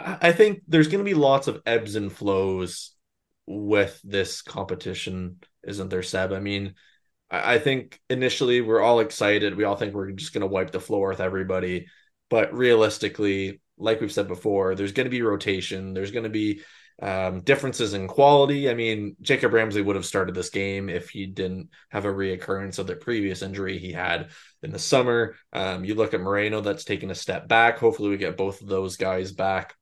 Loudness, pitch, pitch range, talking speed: -24 LUFS, 100 Hz, 95-115 Hz, 195 wpm